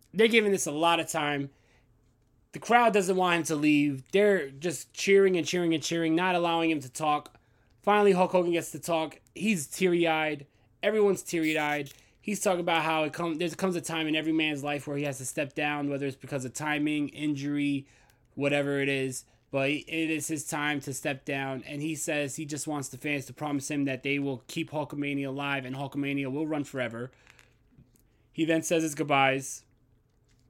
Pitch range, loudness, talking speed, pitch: 140-165 Hz, -28 LUFS, 200 wpm, 150 Hz